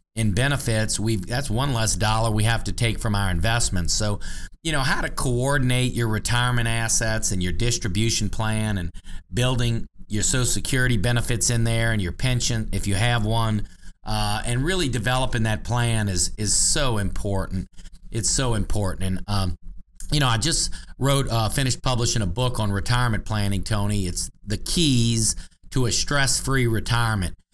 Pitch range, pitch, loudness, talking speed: 100-120 Hz, 110 Hz, -23 LUFS, 170 wpm